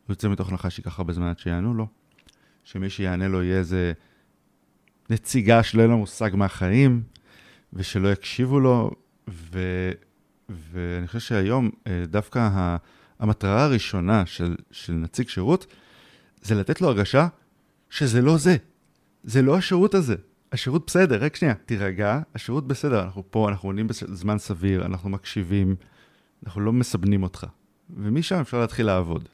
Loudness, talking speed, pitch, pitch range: -23 LUFS, 140 wpm, 105 Hz, 95-125 Hz